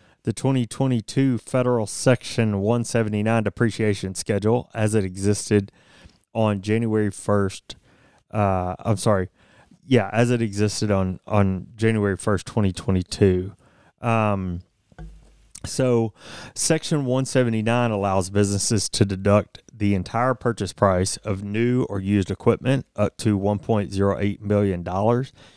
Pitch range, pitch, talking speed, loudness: 100-120 Hz, 105 Hz, 110 wpm, -22 LUFS